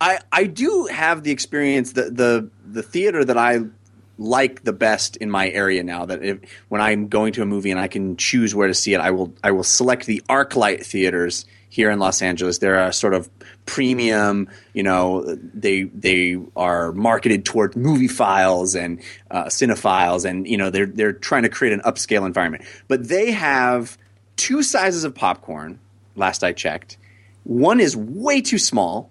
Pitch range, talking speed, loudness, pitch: 95-125 Hz, 185 wpm, -19 LUFS, 105 Hz